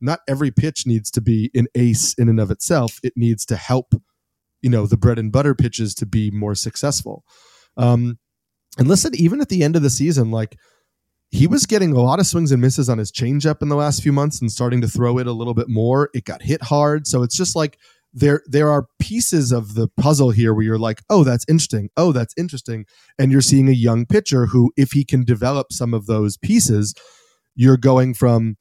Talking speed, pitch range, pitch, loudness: 225 wpm, 115-145 Hz, 125 Hz, -17 LUFS